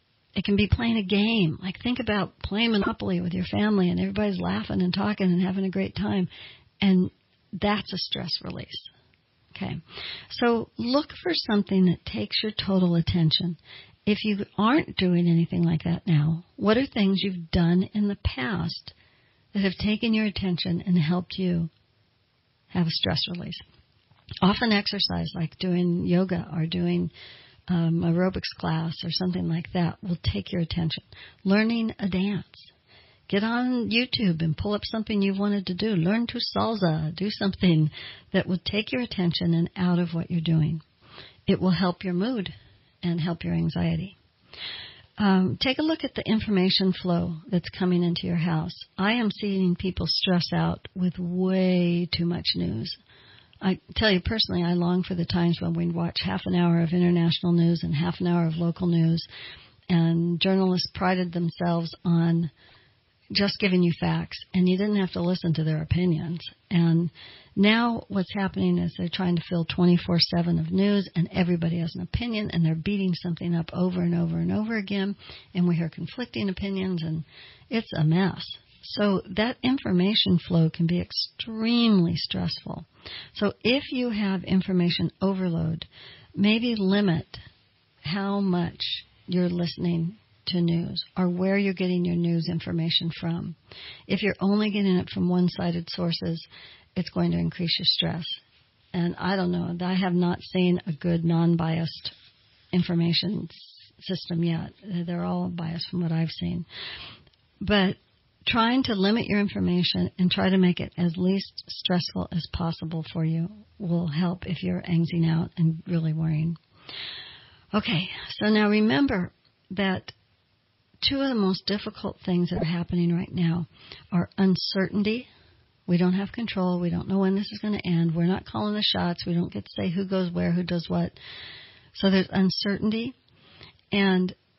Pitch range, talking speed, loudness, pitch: 170-195 Hz, 165 wpm, -26 LUFS, 180 Hz